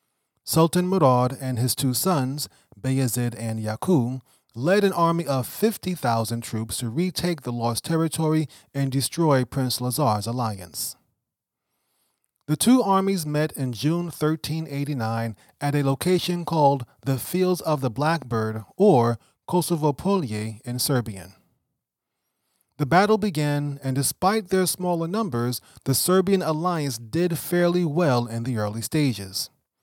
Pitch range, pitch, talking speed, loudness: 120-175 Hz, 140 Hz, 130 wpm, -24 LUFS